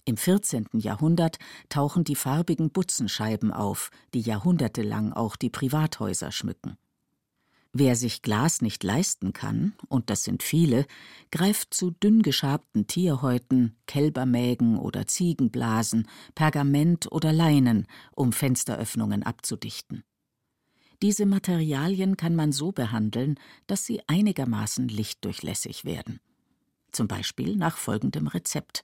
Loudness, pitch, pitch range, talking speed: -26 LUFS, 140 Hz, 115-170 Hz, 110 wpm